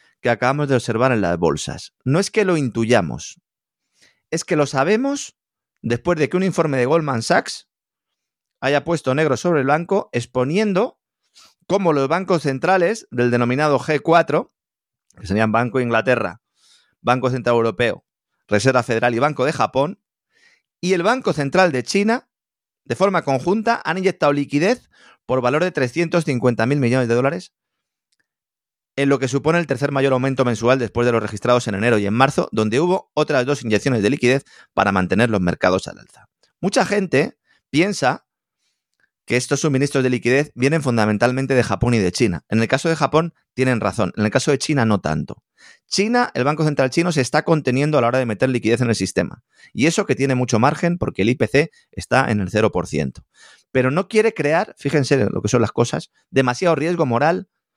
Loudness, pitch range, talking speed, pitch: -19 LUFS, 120-165 Hz, 185 wpm, 135 Hz